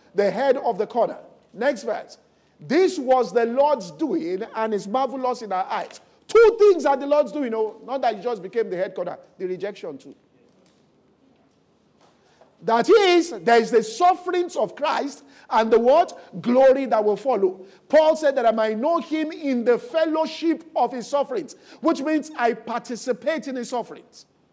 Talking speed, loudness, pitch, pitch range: 175 wpm, -22 LUFS, 255 Hz, 225-310 Hz